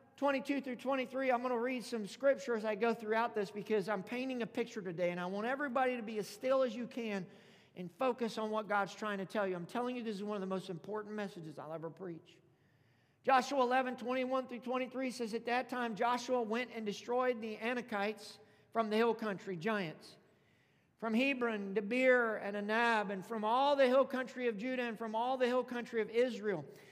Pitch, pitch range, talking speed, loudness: 230 Hz, 205-250 Hz, 210 wpm, -36 LUFS